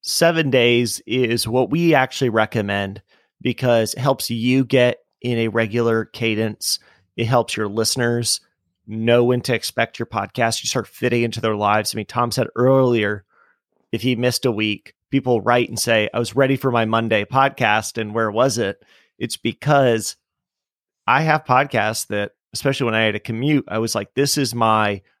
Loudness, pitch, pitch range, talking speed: -19 LUFS, 115 Hz, 110-125 Hz, 180 wpm